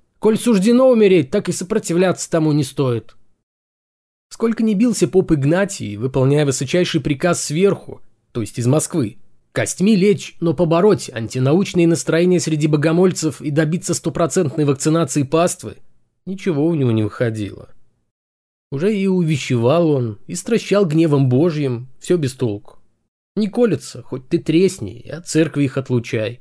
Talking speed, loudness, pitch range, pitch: 140 wpm, -17 LUFS, 130-180 Hz, 160 Hz